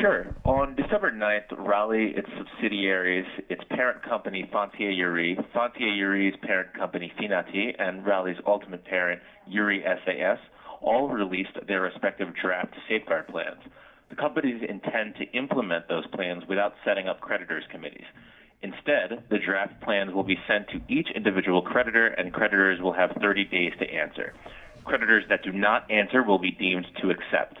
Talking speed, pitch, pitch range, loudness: 155 wpm, 100 Hz, 95-110 Hz, -26 LUFS